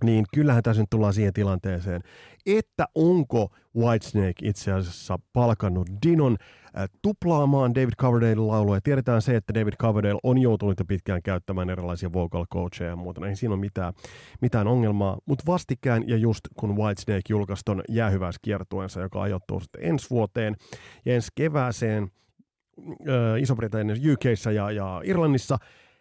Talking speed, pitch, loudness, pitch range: 140 wpm, 110 Hz, -25 LUFS, 95-125 Hz